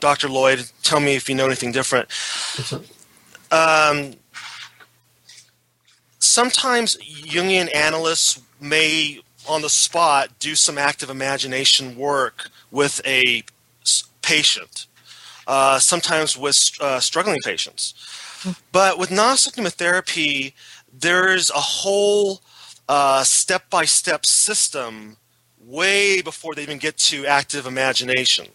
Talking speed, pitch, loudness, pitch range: 105 wpm, 150 Hz, -17 LUFS, 135-175 Hz